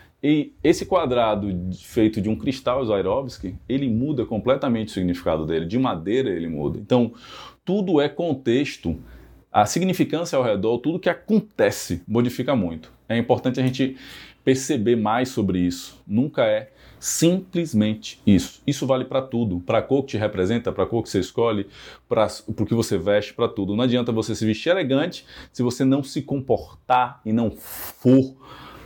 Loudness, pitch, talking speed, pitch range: -22 LUFS, 120 Hz, 165 wpm, 105-135 Hz